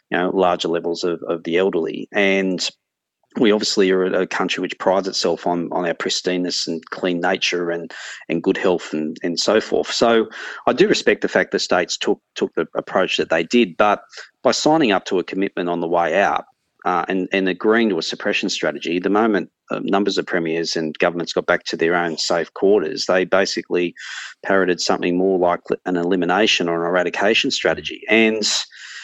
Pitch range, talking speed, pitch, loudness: 85-95 Hz, 195 wpm, 90 Hz, -19 LUFS